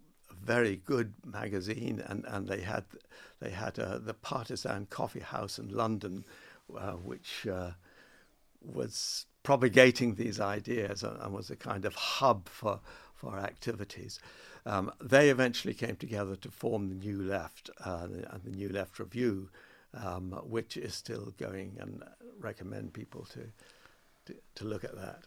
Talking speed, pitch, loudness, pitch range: 150 wpm, 105 Hz, -34 LUFS, 95-120 Hz